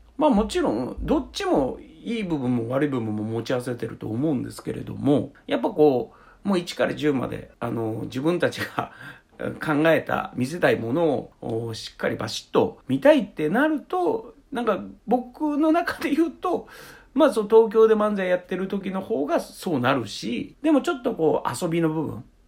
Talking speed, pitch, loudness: 335 characters per minute, 195 Hz, -24 LUFS